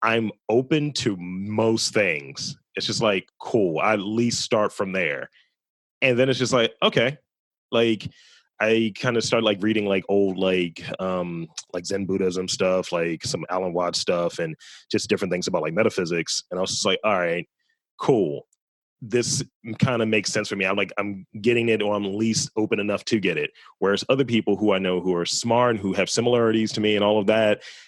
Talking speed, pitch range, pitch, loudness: 205 wpm, 95-115 Hz, 105 Hz, -23 LUFS